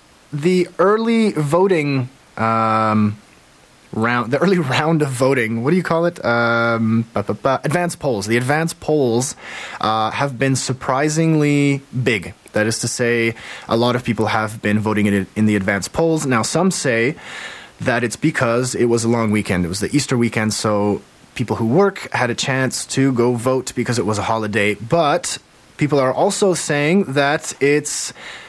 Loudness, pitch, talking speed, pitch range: -18 LUFS, 125 Hz, 175 wpm, 110-150 Hz